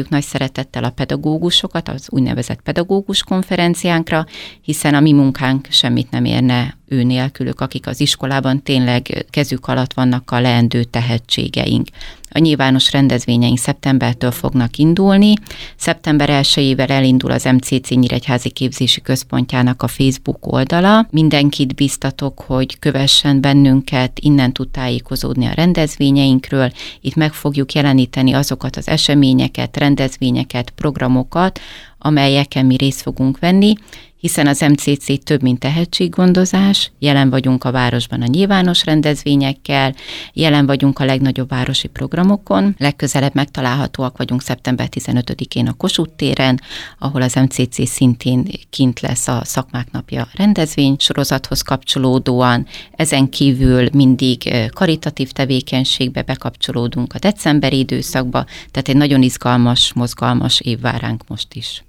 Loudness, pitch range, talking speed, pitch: -15 LUFS, 125-145 Hz, 120 wpm, 135 Hz